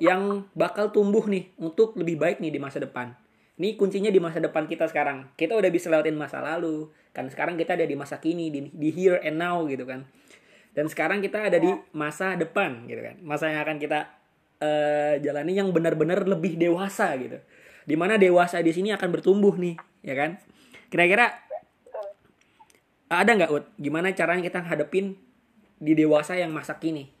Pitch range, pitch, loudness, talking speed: 155-195 Hz, 170 Hz, -25 LUFS, 175 wpm